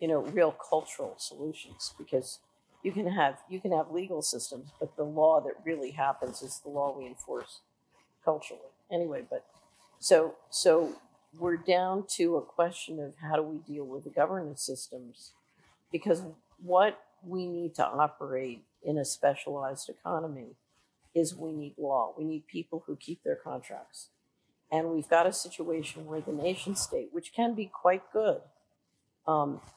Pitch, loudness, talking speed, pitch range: 160 Hz, -32 LUFS, 160 wpm, 145-180 Hz